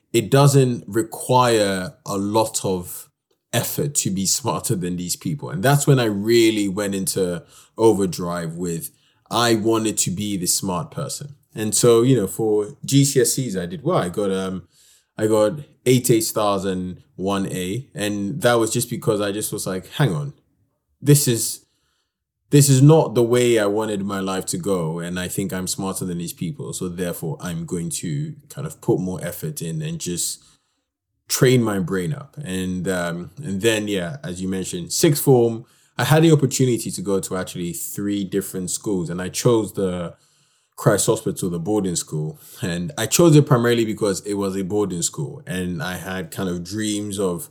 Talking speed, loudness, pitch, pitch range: 185 wpm, -21 LUFS, 105 Hz, 95-135 Hz